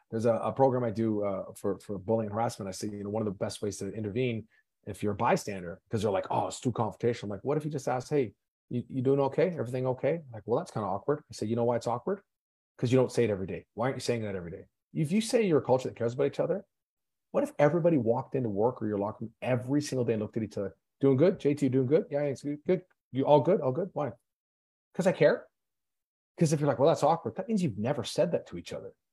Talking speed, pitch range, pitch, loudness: 285 wpm, 110-145 Hz, 125 Hz, -30 LUFS